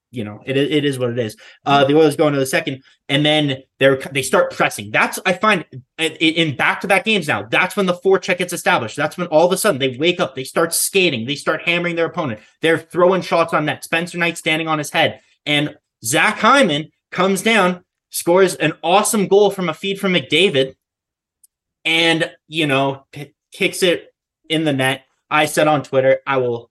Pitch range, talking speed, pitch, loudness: 135-180 Hz, 215 wpm, 160 Hz, -17 LUFS